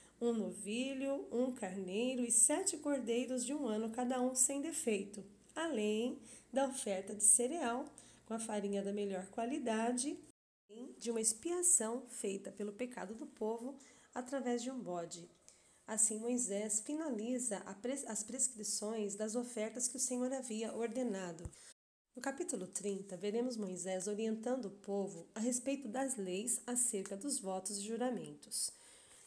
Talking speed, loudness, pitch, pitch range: 135 wpm, -37 LUFS, 235 Hz, 205-255 Hz